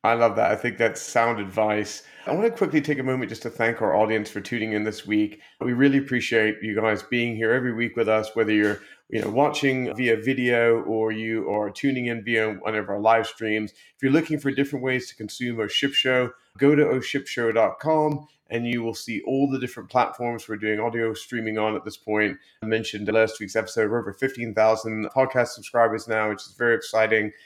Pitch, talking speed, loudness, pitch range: 115 Hz, 220 wpm, -24 LUFS, 110-125 Hz